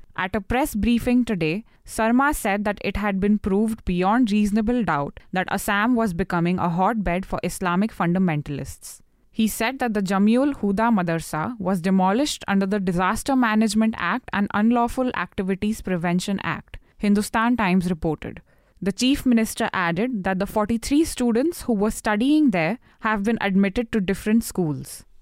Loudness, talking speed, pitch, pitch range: -22 LUFS, 150 wpm, 210 Hz, 185-230 Hz